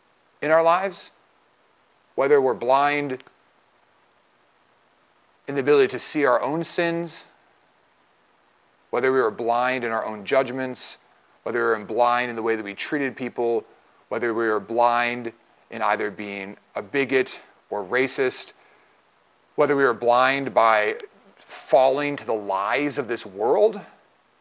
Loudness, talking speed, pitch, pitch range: -23 LUFS, 140 wpm, 130 Hz, 115-155 Hz